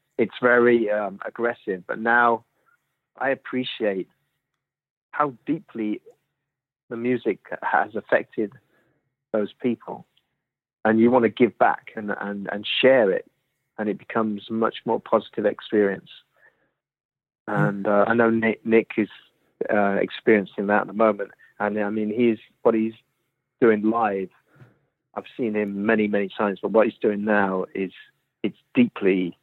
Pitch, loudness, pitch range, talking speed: 110 Hz, -23 LUFS, 105-120 Hz, 140 wpm